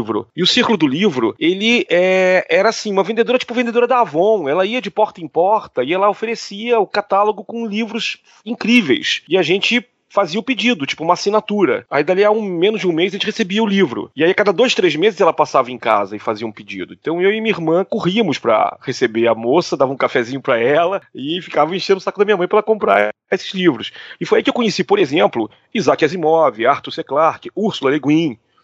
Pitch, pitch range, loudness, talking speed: 200 Hz, 170-230 Hz, -16 LUFS, 230 wpm